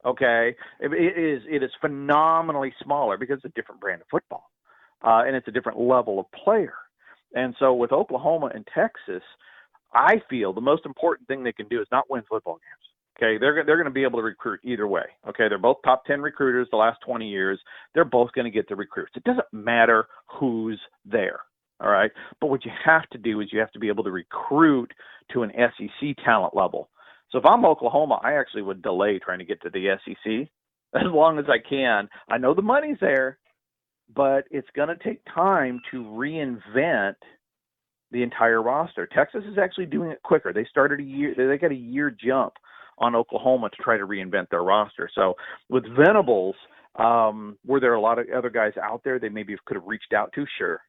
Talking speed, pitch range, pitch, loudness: 205 wpm, 115-145 Hz, 130 Hz, -23 LUFS